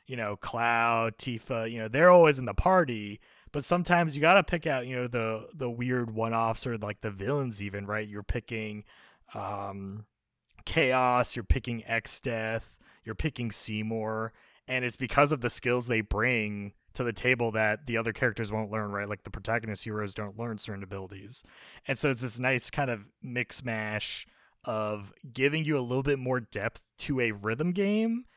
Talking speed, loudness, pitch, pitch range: 185 wpm, -29 LUFS, 115 Hz, 105-130 Hz